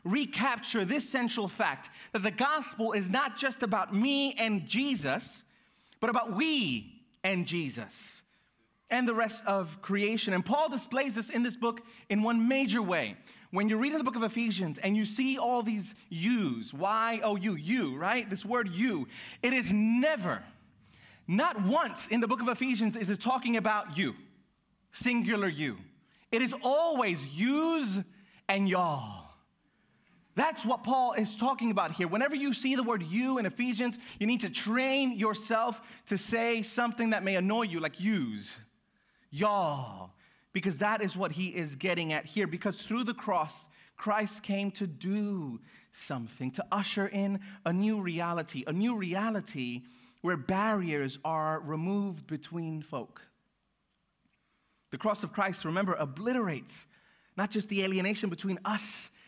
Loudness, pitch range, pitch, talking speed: -31 LUFS, 190-240 Hz, 215 Hz, 155 wpm